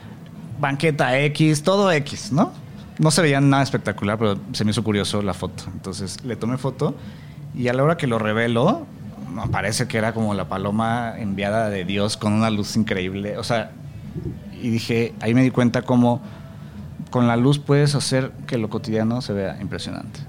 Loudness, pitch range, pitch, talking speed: -21 LUFS, 105-135 Hz, 115 Hz, 185 wpm